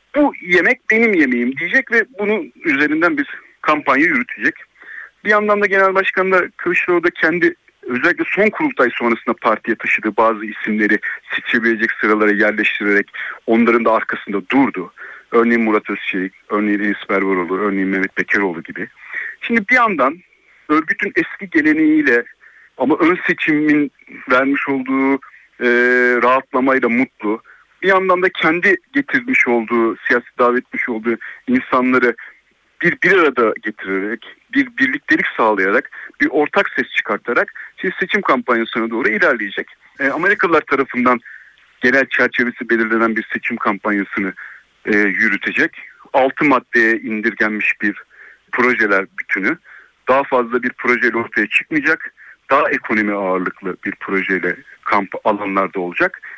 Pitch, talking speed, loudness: 125 Hz, 120 wpm, -16 LUFS